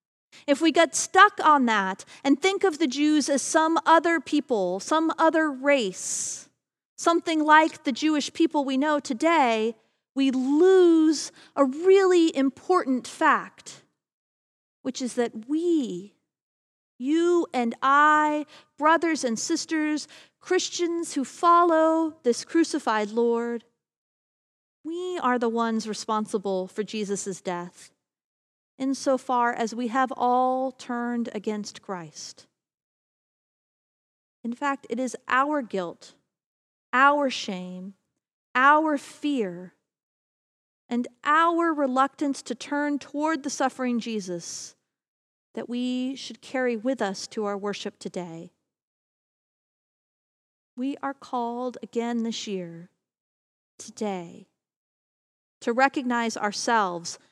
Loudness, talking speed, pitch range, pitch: -24 LUFS, 110 wpm, 225-305 Hz, 260 Hz